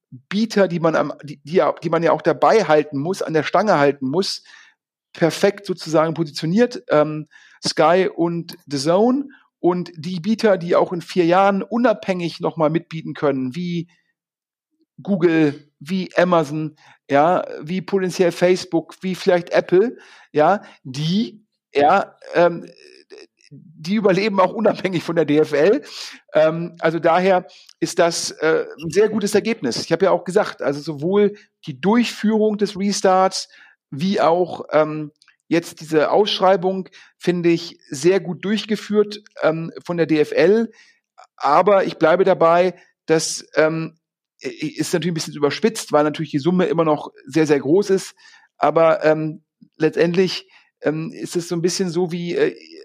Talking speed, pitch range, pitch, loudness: 145 wpm, 160-200 Hz, 175 Hz, -19 LUFS